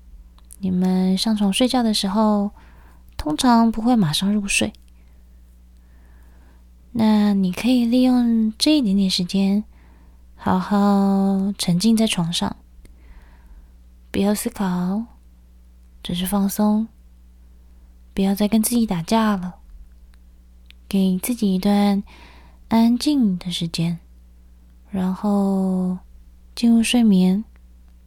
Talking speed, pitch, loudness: 150 characters per minute, 185 Hz, -20 LUFS